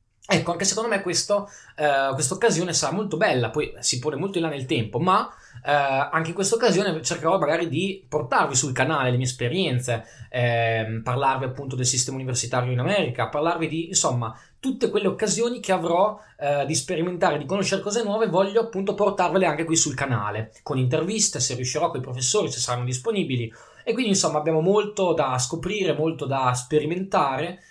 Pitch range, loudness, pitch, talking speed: 130-190 Hz, -23 LUFS, 155 Hz, 180 wpm